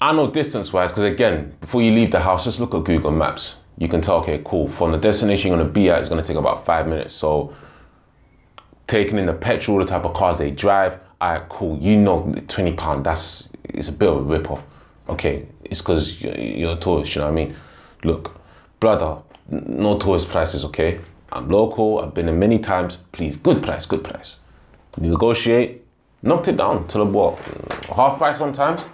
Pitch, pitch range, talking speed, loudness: 95 Hz, 80-105 Hz, 210 wpm, -20 LUFS